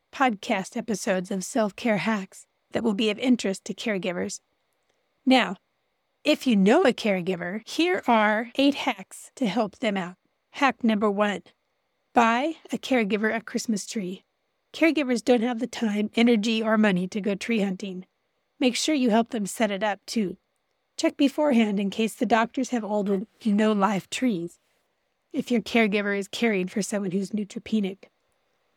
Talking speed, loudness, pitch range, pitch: 165 wpm, -25 LUFS, 205-245 Hz, 220 Hz